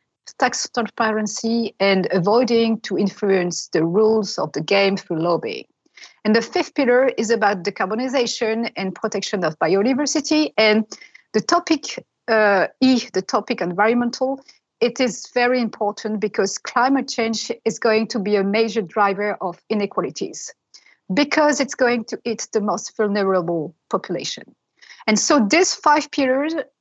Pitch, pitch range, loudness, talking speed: 220 Hz, 200-250 Hz, -20 LUFS, 140 wpm